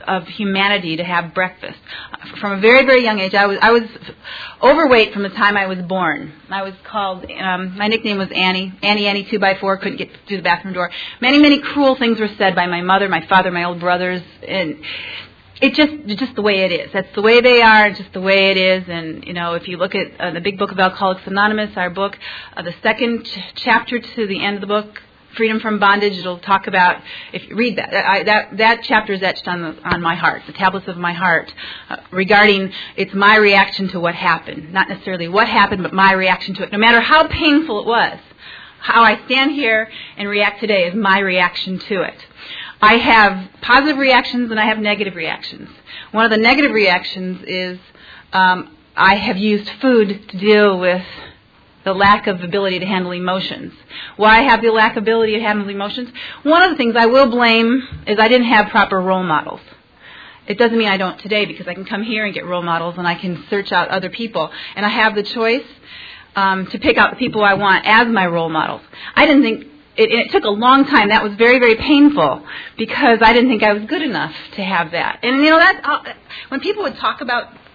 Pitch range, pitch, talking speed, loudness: 185-230 Hz, 205 Hz, 225 wpm, -14 LUFS